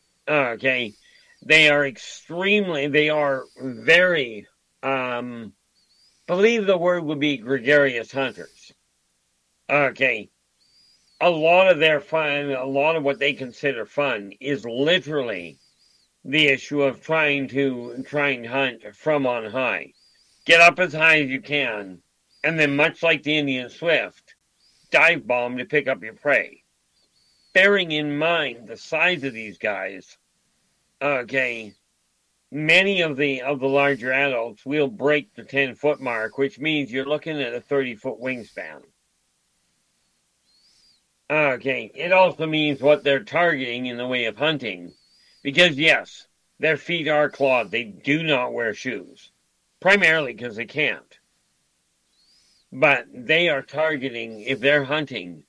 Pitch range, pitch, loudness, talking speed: 120-150 Hz, 135 Hz, -21 LUFS, 135 wpm